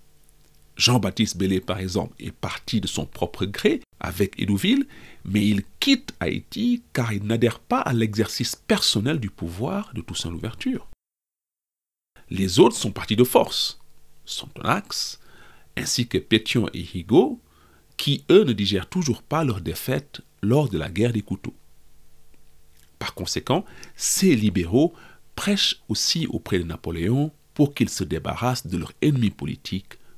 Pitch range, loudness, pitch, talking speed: 95-130 Hz, -23 LUFS, 105 Hz, 140 wpm